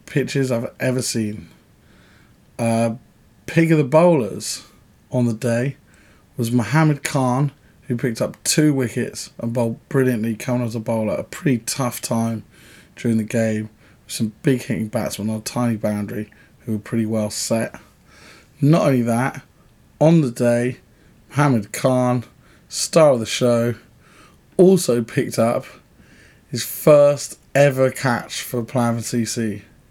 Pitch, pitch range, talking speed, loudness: 120 Hz, 115-135 Hz, 140 wpm, -20 LUFS